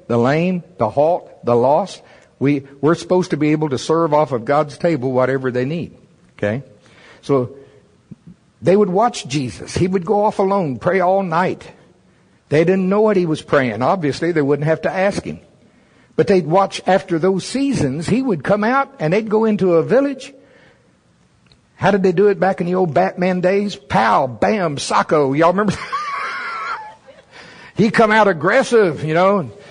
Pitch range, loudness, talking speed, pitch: 150-200 Hz, -17 LUFS, 175 wpm, 180 Hz